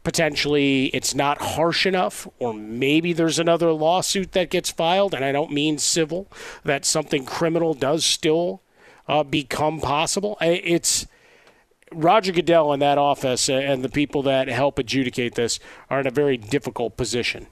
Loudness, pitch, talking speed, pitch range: -21 LUFS, 145 Hz, 155 wpm, 135-170 Hz